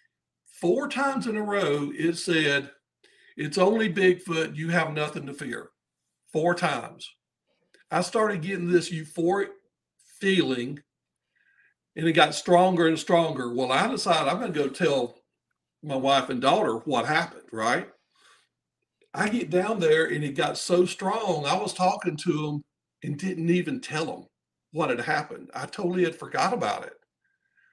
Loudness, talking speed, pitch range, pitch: -26 LUFS, 155 wpm, 150-195 Hz, 170 Hz